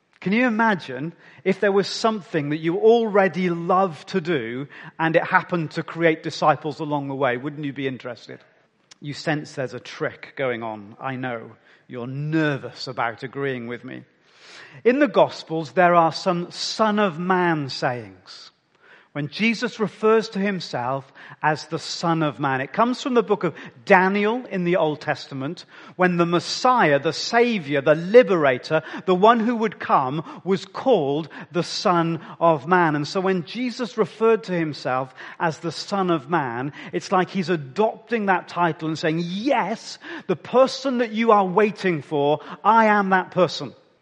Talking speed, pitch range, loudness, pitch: 165 wpm, 145-200 Hz, -22 LUFS, 170 Hz